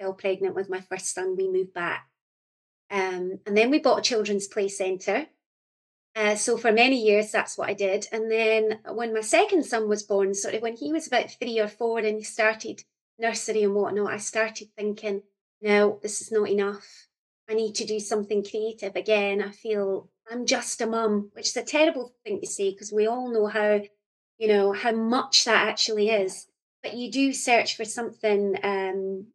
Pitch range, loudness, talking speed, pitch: 200-225 Hz, -25 LUFS, 195 wpm, 210 Hz